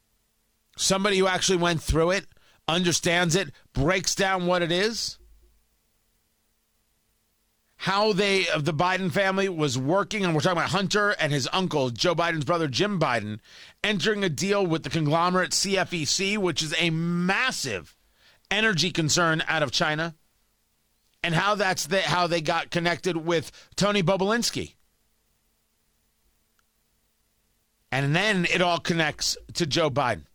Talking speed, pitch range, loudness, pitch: 135 wpm, 150-190 Hz, -24 LUFS, 170 Hz